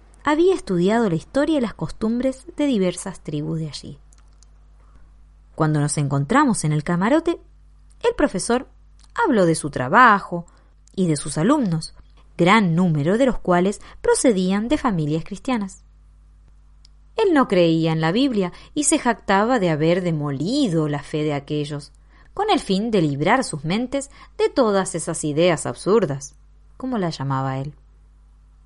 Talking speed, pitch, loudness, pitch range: 145 wpm, 175 Hz, -20 LUFS, 150-245 Hz